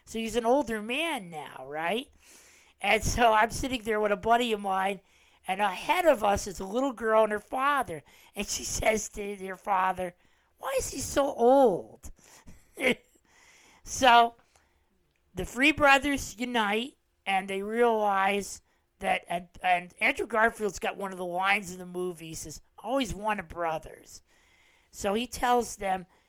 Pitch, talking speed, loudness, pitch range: 210 Hz, 160 wpm, -27 LUFS, 190-245 Hz